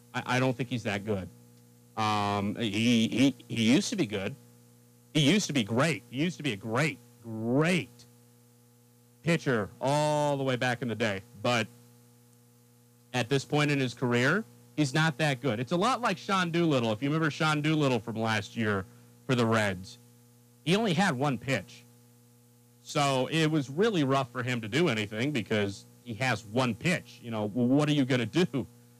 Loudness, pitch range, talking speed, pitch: -29 LUFS, 115-140 Hz, 190 wpm, 120 Hz